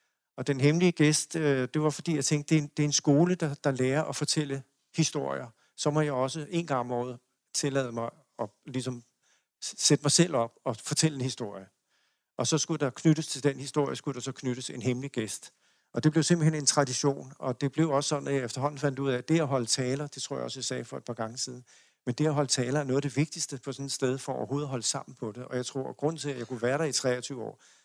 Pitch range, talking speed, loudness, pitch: 130-150 Hz, 265 wpm, -29 LUFS, 140 Hz